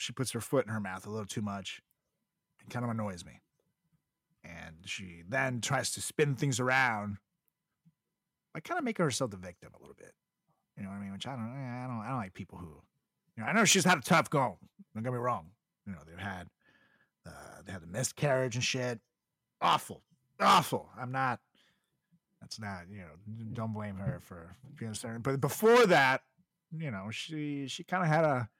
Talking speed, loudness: 205 wpm, -32 LUFS